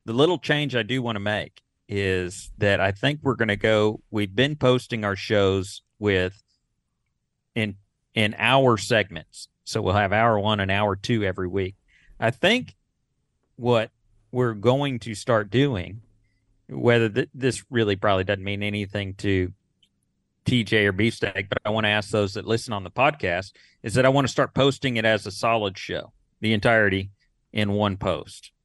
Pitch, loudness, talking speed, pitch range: 105 Hz, -23 LUFS, 175 wpm, 100-120 Hz